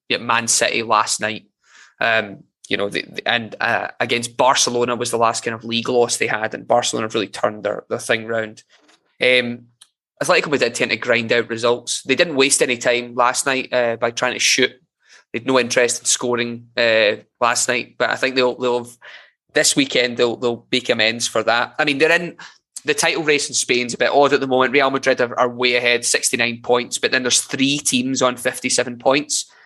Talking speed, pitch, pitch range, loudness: 225 wpm, 125 Hz, 120-130 Hz, -18 LUFS